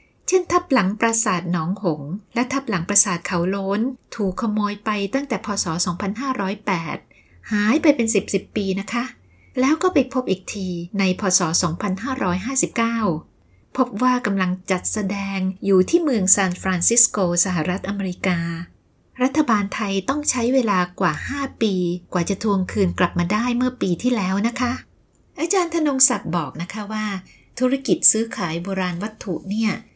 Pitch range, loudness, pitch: 185-245 Hz, -20 LUFS, 200 Hz